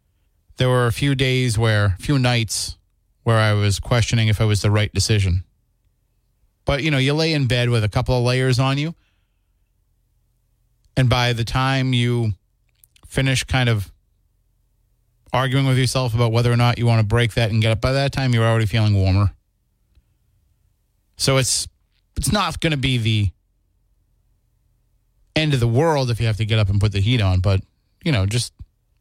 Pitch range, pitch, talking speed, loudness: 100-125 Hz, 110 Hz, 185 wpm, -19 LUFS